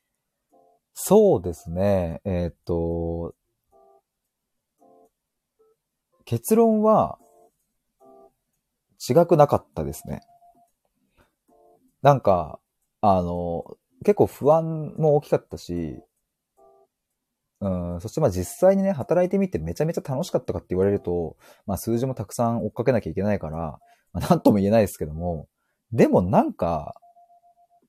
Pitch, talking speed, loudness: 115 Hz, 245 characters per minute, -23 LUFS